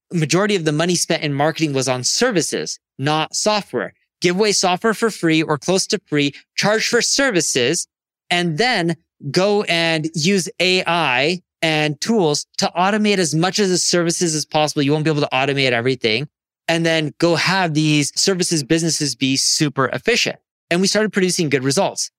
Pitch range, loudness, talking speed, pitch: 150-185 Hz, -17 LUFS, 175 wpm, 165 Hz